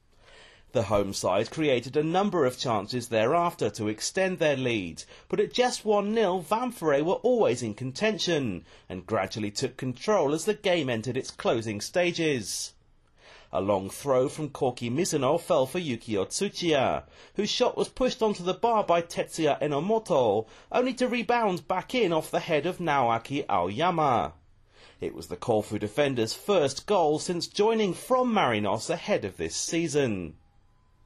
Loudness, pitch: -27 LUFS, 155 Hz